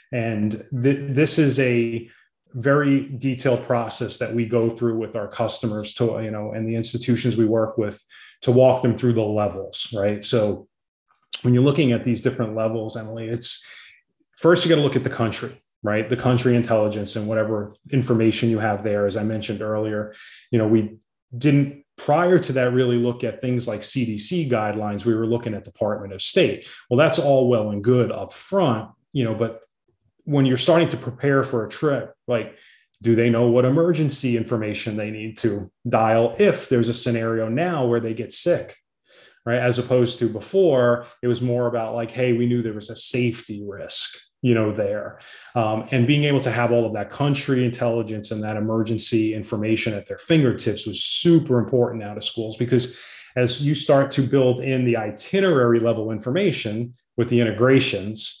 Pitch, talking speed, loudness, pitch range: 120 Hz, 185 wpm, -21 LUFS, 110-130 Hz